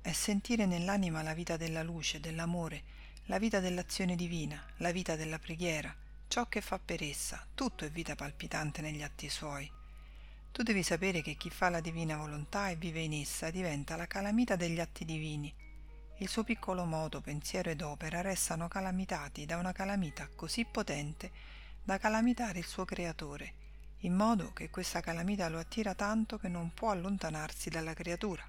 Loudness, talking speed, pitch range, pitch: -37 LUFS, 170 wpm, 155-190 Hz, 170 Hz